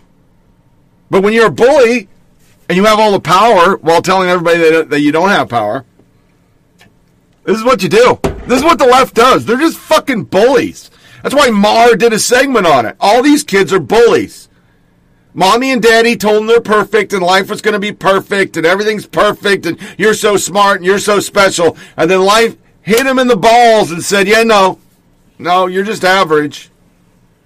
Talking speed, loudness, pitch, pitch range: 195 wpm, -9 LUFS, 205 Hz, 185-230 Hz